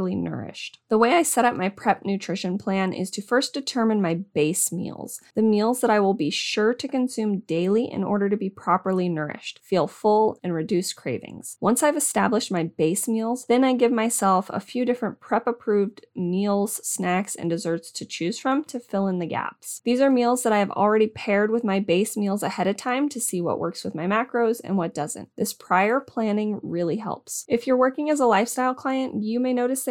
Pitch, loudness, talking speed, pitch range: 210 Hz, -24 LUFS, 215 wpm, 185-240 Hz